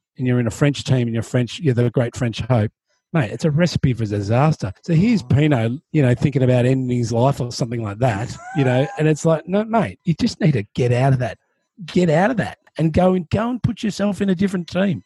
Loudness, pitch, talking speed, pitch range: -19 LUFS, 140 Hz, 255 wpm, 125-180 Hz